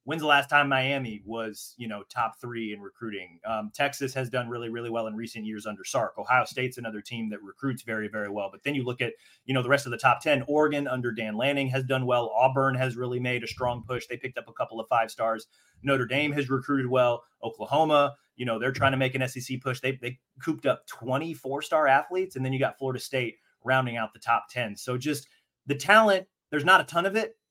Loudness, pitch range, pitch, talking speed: -27 LUFS, 115-140 Hz, 130 Hz, 240 wpm